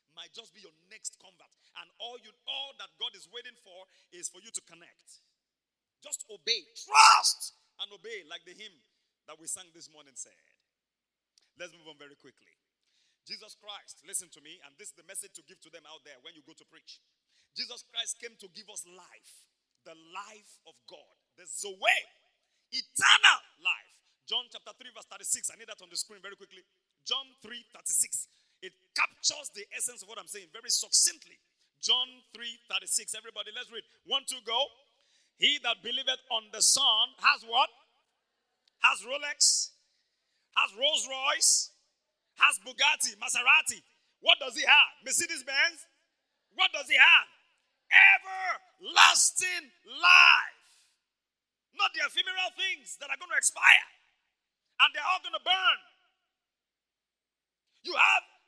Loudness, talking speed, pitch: -25 LUFS, 155 wpm, 240 Hz